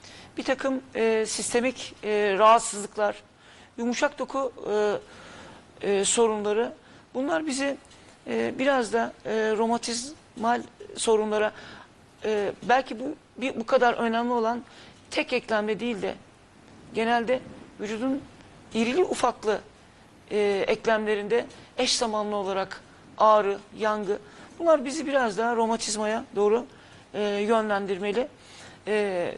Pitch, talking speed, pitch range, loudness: 230 Hz, 100 wpm, 215-255 Hz, -26 LUFS